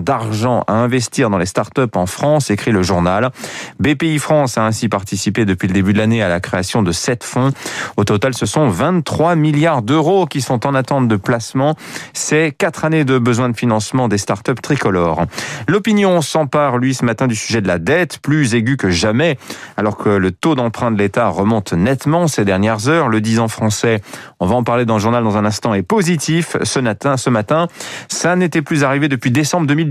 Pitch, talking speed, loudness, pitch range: 125 Hz, 205 wpm, -15 LUFS, 110-150 Hz